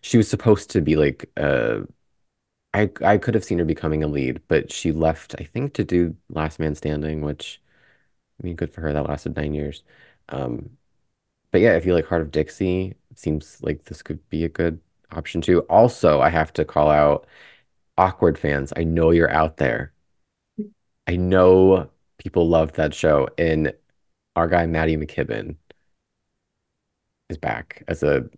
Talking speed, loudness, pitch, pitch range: 175 wpm, -21 LUFS, 80 Hz, 75-90 Hz